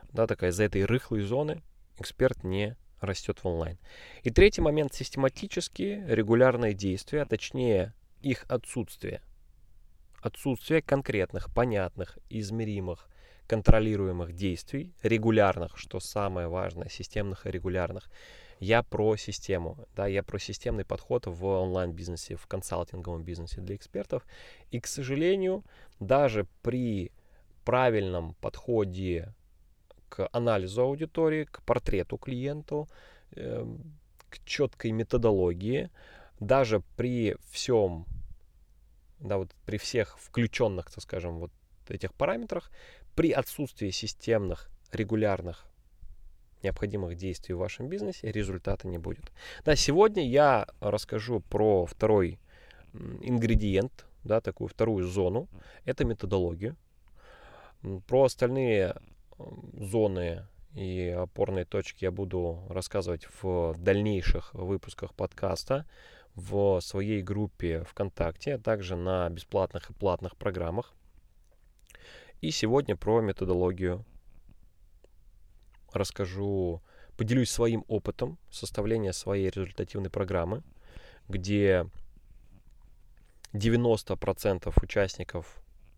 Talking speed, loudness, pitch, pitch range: 100 wpm, -30 LUFS, 100 Hz, 90-115 Hz